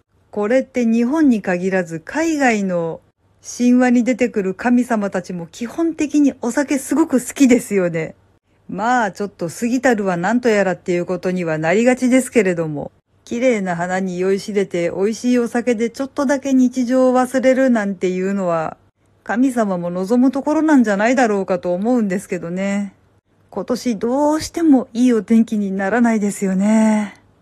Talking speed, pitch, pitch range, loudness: 345 characters per minute, 225 Hz, 190-255 Hz, -17 LUFS